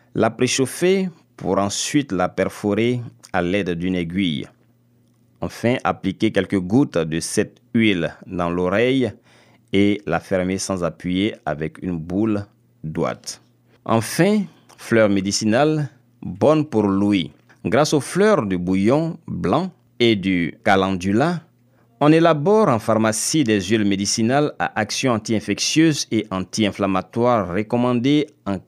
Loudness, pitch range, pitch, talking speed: -20 LUFS, 95-130 Hz, 110 Hz, 120 wpm